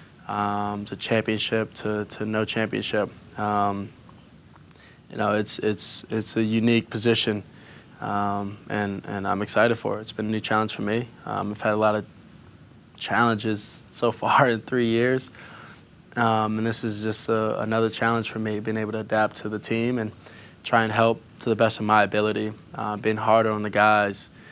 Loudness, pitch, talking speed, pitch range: -24 LUFS, 110 Hz, 185 wpm, 105-115 Hz